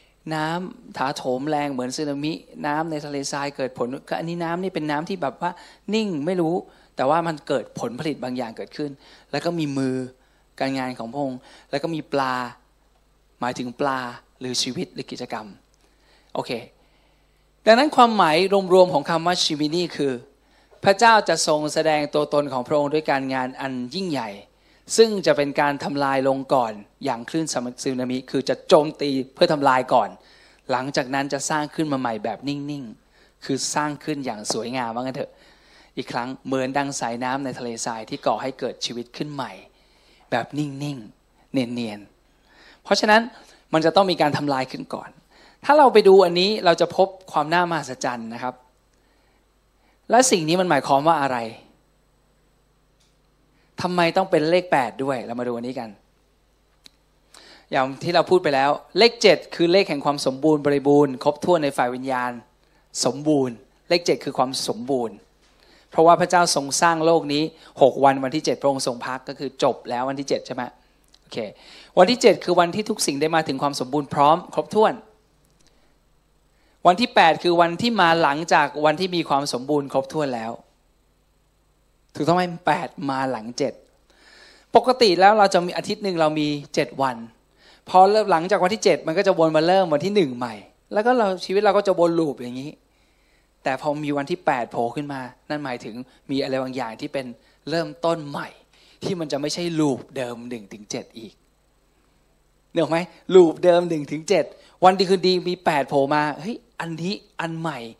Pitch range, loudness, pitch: 130-175 Hz, -21 LUFS, 150 Hz